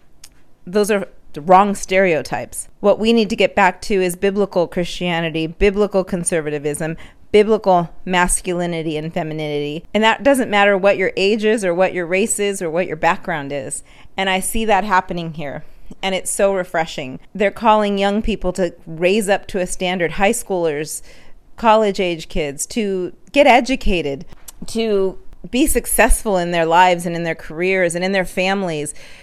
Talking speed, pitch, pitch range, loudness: 165 wpm, 185 Hz, 170-205 Hz, -17 LUFS